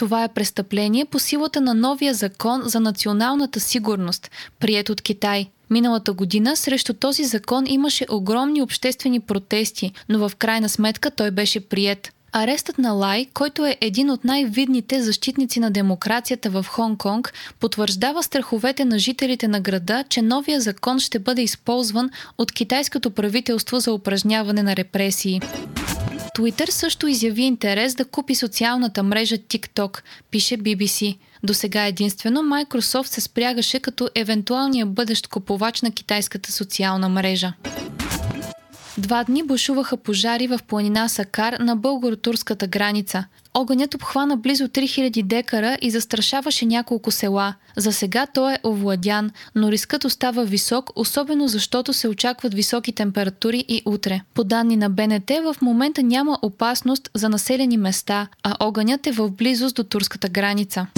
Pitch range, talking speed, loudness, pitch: 210-255 Hz, 140 wpm, -21 LUFS, 230 Hz